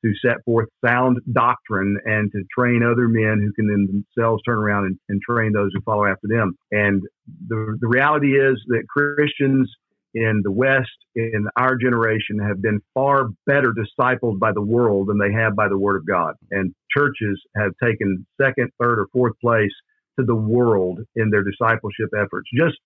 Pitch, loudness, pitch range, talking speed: 110 Hz, -20 LUFS, 105-125 Hz, 185 wpm